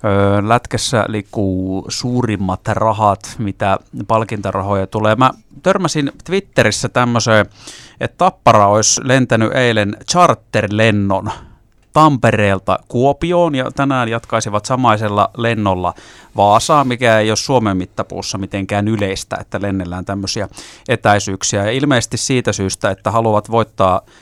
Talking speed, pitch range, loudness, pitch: 105 wpm, 100-125 Hz, -15 LUFS, 110 Hz